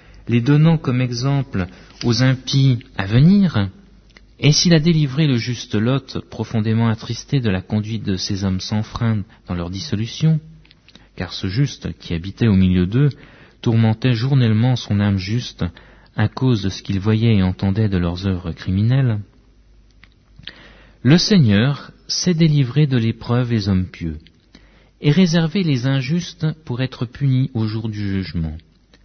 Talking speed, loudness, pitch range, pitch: 150 wpm, -18 LUFS, 100-135 Hz, 115 Hz